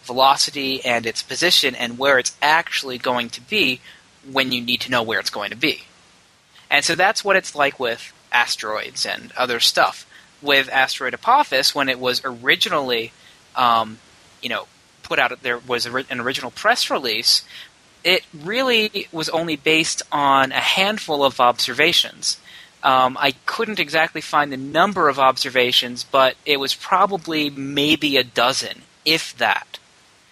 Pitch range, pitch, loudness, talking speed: 125-160 Hz, 135 Hz, -18 LUFS, 155 wpm